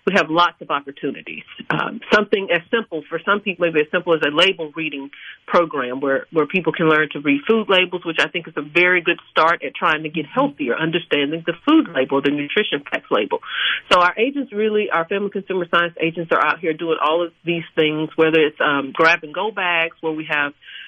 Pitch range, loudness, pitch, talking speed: 155-200 Hz, -19 LUFS, 170 Hz, 220 wpm